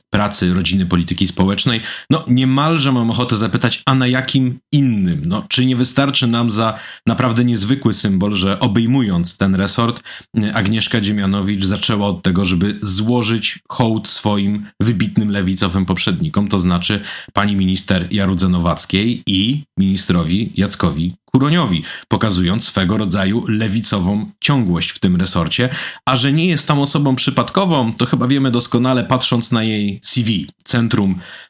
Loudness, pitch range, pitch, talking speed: -16 LUFS, 95-130 Hz, 110 Hz, 135 wpm